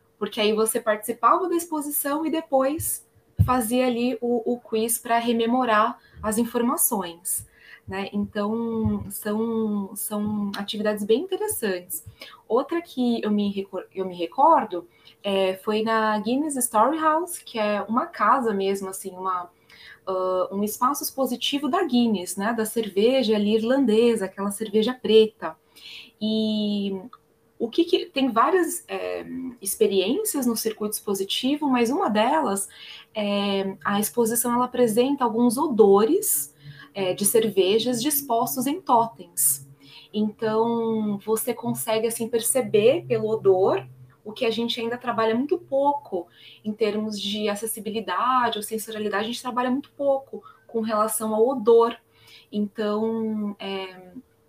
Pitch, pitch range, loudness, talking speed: 220 Hz, 205-245 Hz, -24 LUFS, 130 wpm